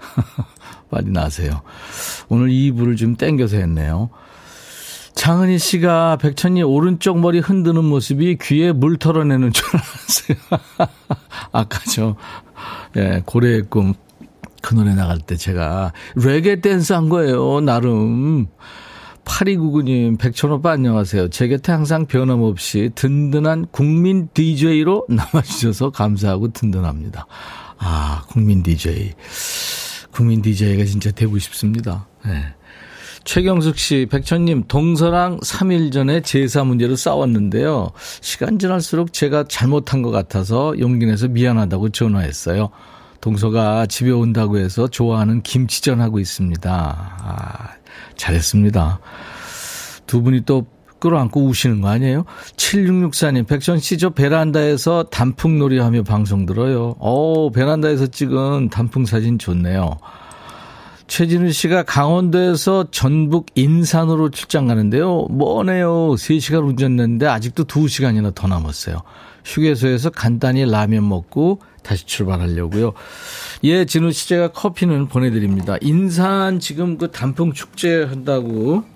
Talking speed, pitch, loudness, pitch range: 275 characters per minute, 130 Hz, -17 LUFS, 105-160 Hz